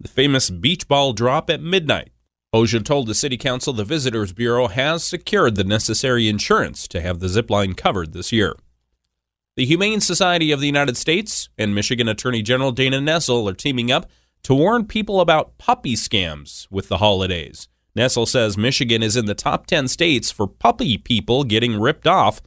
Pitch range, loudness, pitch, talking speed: 100-140 Hz, -18 LUFS, 120 Hz, 180 wpm